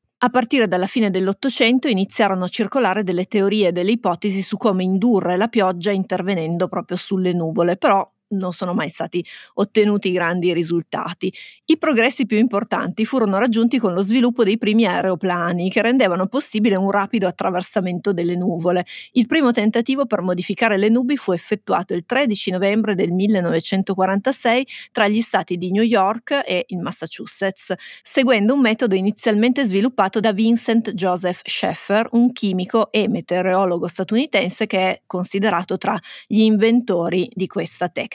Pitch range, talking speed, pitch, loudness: 185-230 Hz, 150 wpm, 200 Hz, -19 LUFS